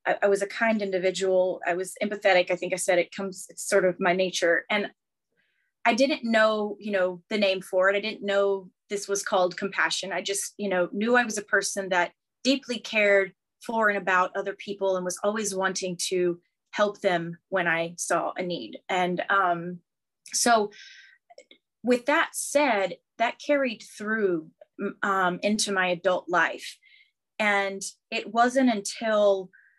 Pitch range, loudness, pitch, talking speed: 185-215 Hz, -26 LUFS, 200 Hz, 165 wpm